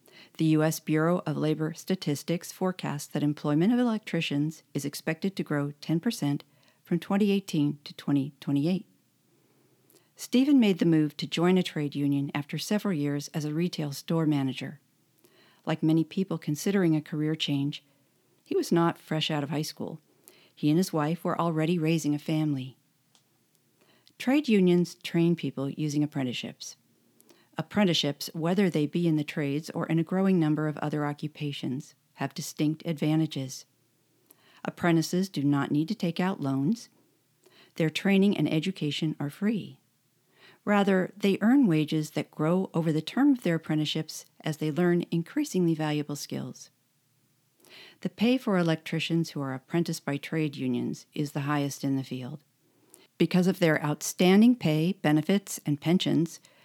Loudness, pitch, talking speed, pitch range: -28 LUFS, 160 Hz, 150 wpm, 150-180 Hz